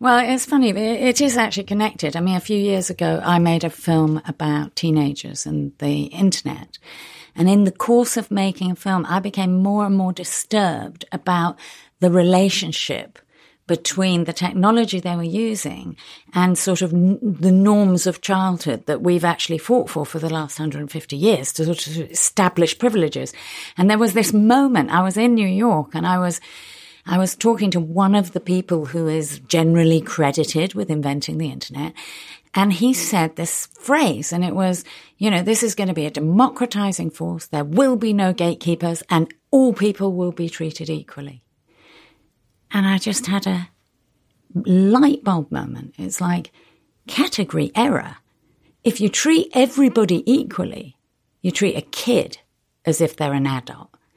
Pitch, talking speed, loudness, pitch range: 180 Hz, 170 wpm, -19 LUFS, 165-210 Hz